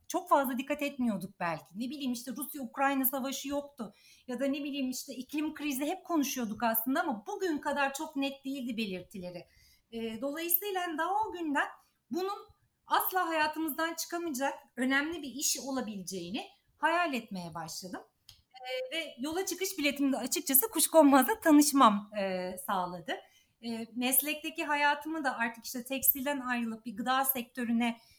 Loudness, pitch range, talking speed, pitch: -31 LUFS, 240-310 Hz, 140 wpm, 275 Hz